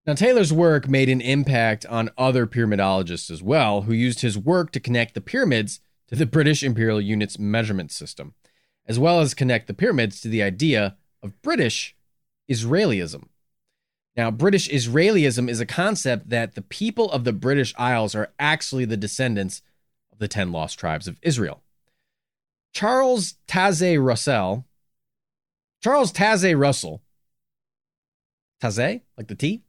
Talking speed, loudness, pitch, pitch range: 145 wpm, -21 LUFS, 125 Hz, 110-155 Hz